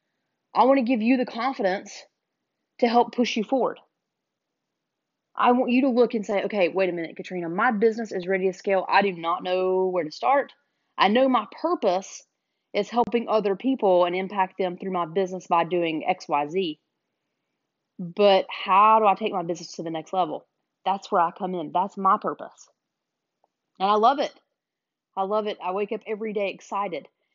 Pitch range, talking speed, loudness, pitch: 185-230 Hz, 195 wpm, -24 LUFS, 195 Hz